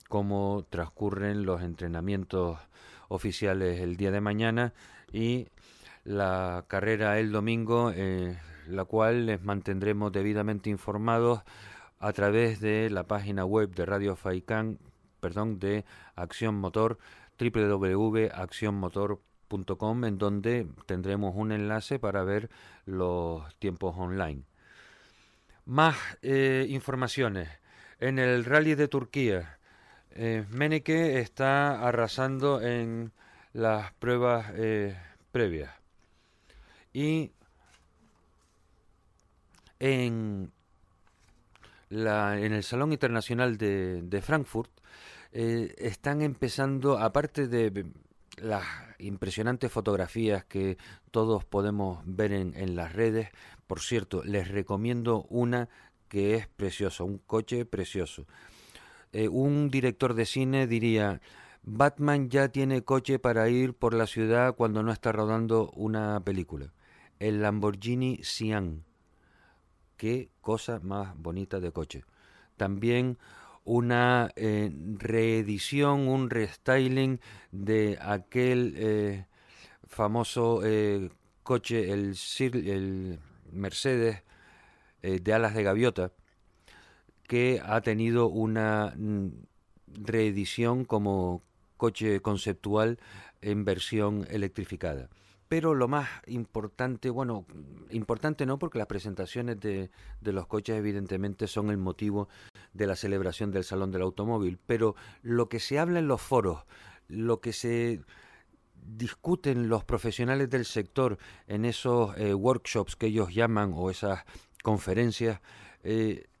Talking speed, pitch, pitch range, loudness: 110 wpm, 105 Hz, 95-120 Hz, -30 LUFS